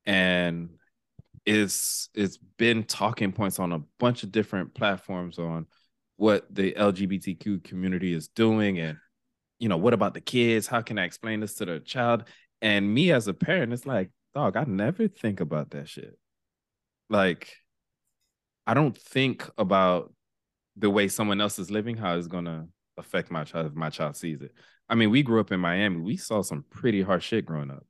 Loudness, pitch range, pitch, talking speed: -27 LUFS, 85-110 Hz, 100 Hz, 185 wpm